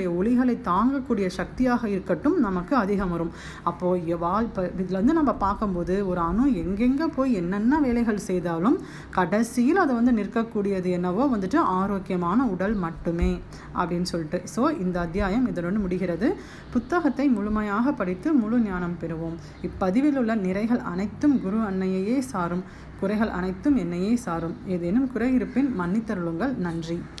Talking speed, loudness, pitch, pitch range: 130 wpm, -25 LUFS, 200 Hz, 180-245 Hz